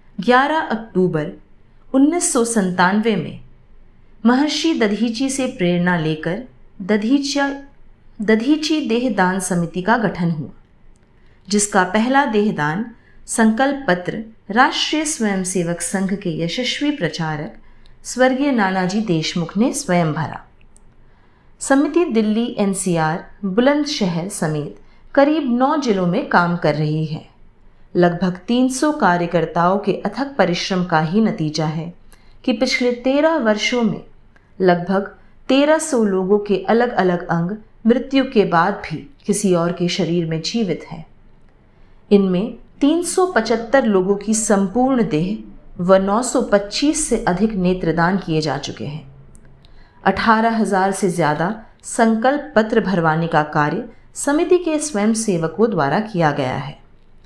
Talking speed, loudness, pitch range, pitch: 115 wpm, -18 LUFS, 175-245 Hz, 205 Hz